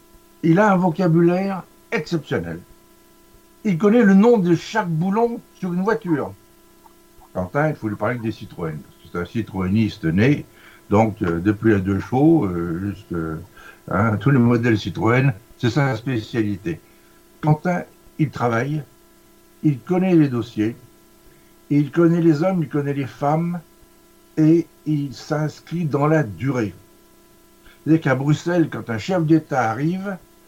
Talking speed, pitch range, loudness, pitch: 145 wpm, 110-170 Hz, -20 LUFS, 150 Hz